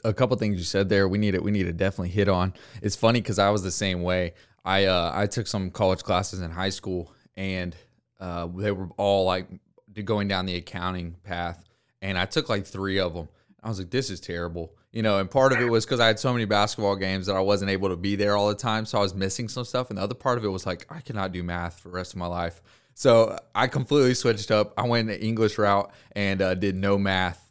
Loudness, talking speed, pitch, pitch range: -25 LUFS, 265 wpm, 100 Hz, 95-110 Hz